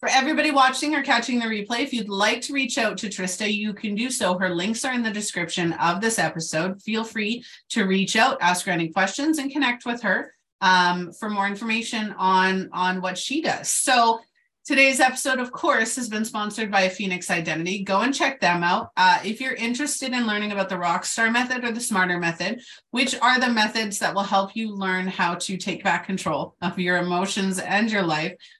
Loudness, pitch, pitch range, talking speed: -22 LUFS, 210 Hz, 185-245 Hz, 210 wpm